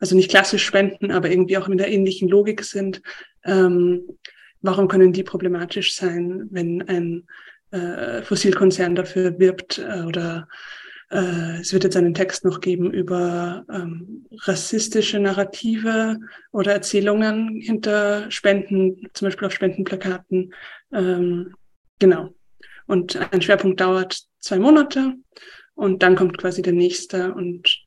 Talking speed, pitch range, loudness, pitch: 130 wpm, 180-200 Hz, -20 LUFS, 190 Hz